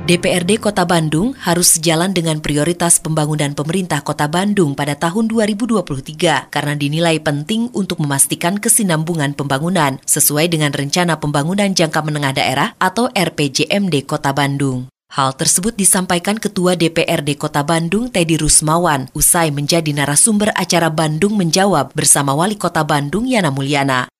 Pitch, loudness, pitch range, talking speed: 165 Hz, -15 LUFS, 150-185 Hz, 130 wpm